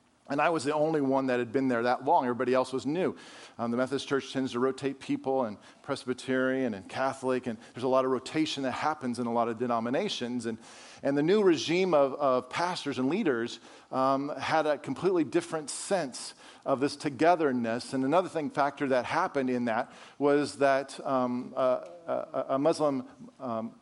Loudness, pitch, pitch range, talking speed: -29 LUFS, 135 Hz, 125-145 Hz, 190 wpm